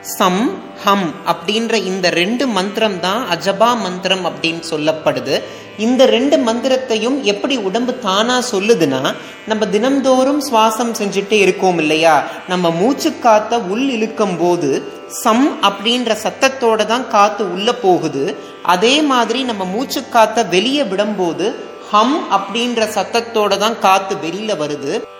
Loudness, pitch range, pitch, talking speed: -15 LUFS, 190-245 Hz, 220 Hz, 120 wpm